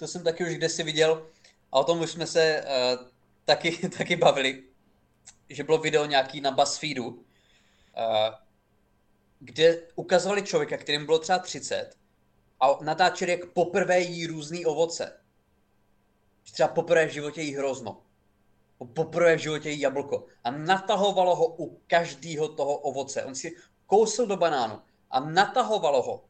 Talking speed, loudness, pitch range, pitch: 145 wpm, -26 LUFS, 140-175 Hz, 160 Hz